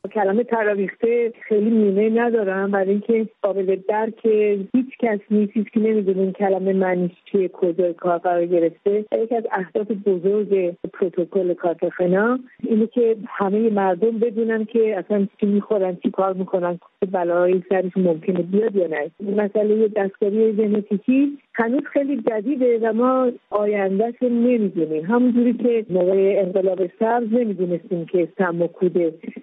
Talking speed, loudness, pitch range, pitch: 140 wpm, -20 LUFS, 190-225 Hz, 205 Hz